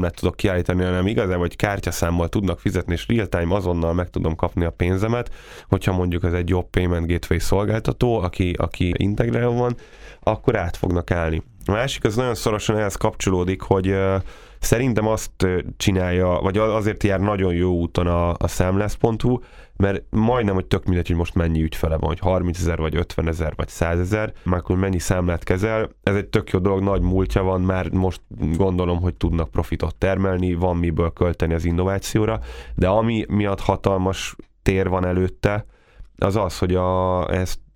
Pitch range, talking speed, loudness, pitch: 85-105 Hz, 170 wpm, -22 LUFS, 95 Hz